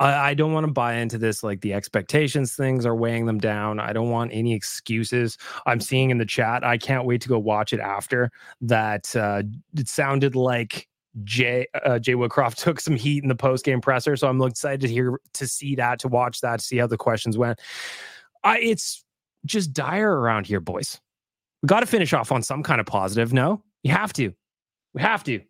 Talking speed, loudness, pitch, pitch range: 215 wpm, -23 LUFS, 125 Hz, 115-140 Hz